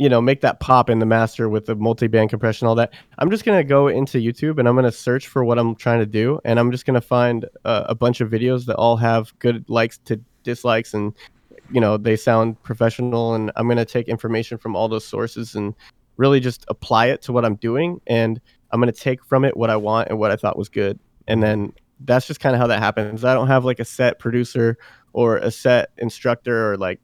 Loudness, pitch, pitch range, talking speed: -19 LUFS, 115 Hz, 110-125 Hz, 255 wpm